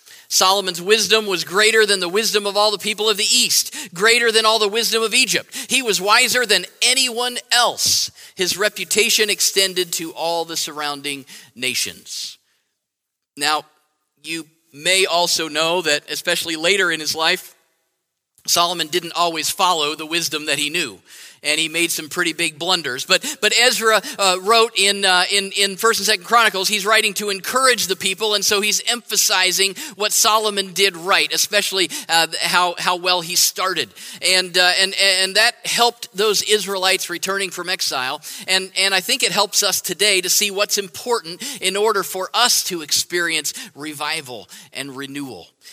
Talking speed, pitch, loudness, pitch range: 170 wpm, 190 Hz, -17 LUFS, 170-215 Hz